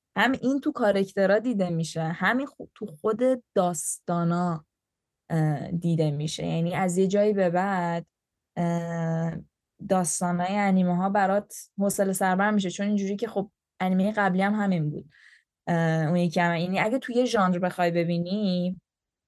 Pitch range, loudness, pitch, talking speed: 170-200 Hz, -26 LUFS, 185 Hz, 135 wpm